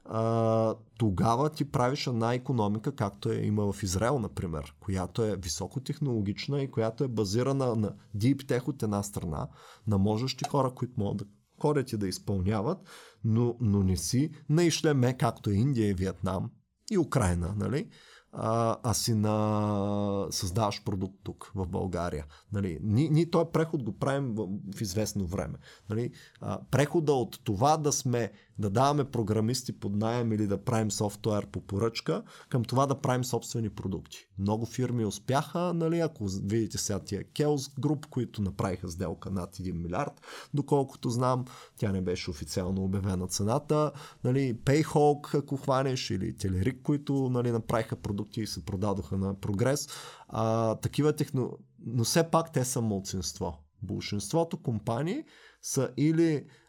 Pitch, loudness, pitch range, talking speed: 115 Hz, -30 LUFS, 100-135 Hz, 150 wpm